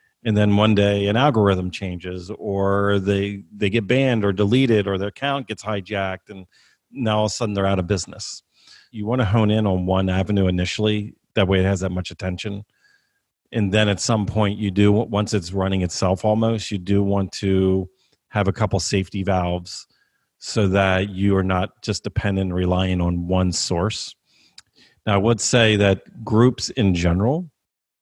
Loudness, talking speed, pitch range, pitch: -21 LUFS, 180 wpm, 95-110 Hz, 100 Hz